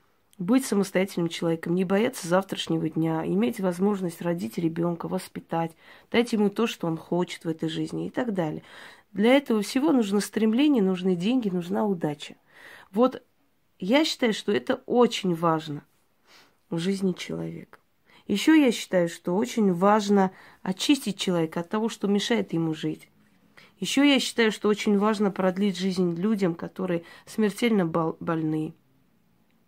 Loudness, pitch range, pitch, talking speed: -25 LUFS, 170-220 Hz, 195 Hz, 140 wpm